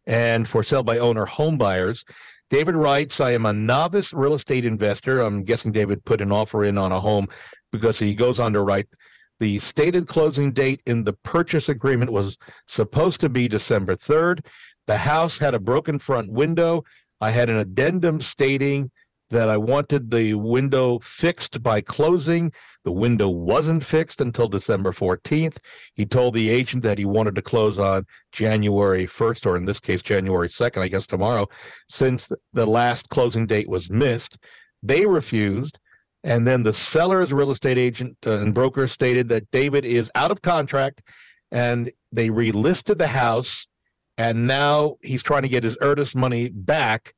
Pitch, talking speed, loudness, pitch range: 120 Hz, 170 wpm, -21 LUFS, 110-140 Hz